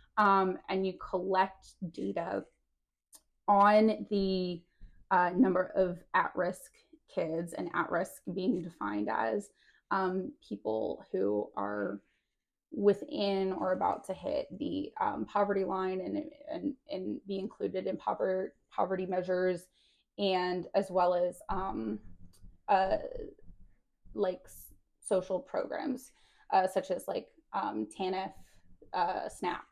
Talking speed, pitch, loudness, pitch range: 110 wpm, 190 Hz, -33 LUFS, 175-200 Hz